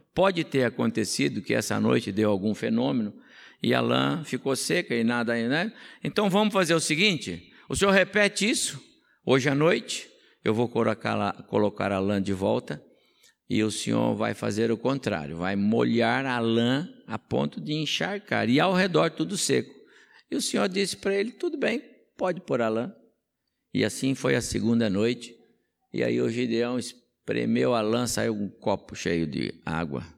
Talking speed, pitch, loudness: 175 wpm, 120 Hz, -26 LUFS